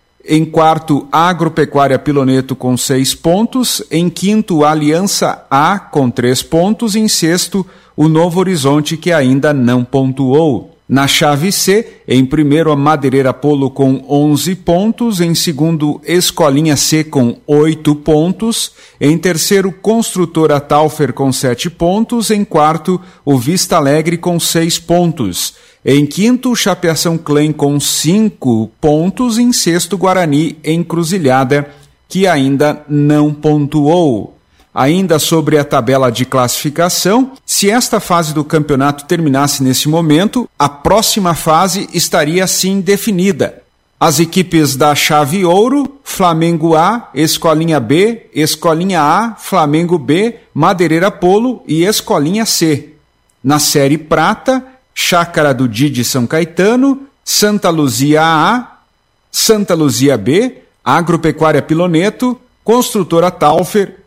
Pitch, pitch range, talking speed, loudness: 160 Hz, 145-190 Hz, 120 wpm, -11 LUFS